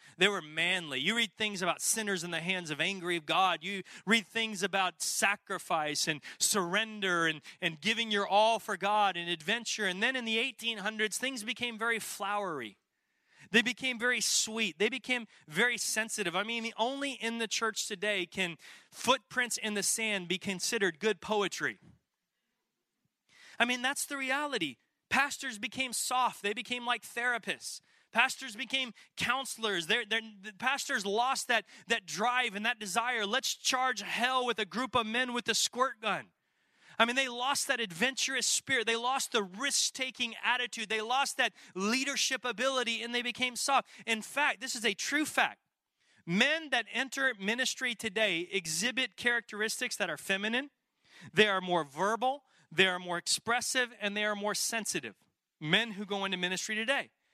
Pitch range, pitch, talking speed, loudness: 200-250 Hz, 225 Hz, 165 wpm, -31 LUFS